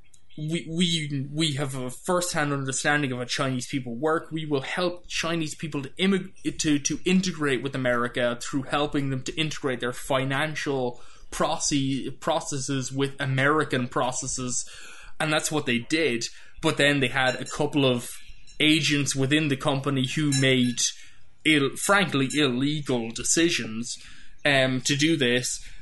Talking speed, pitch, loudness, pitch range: 145 wpm, 140 Hz, -25 LUFS, 130-155 Hz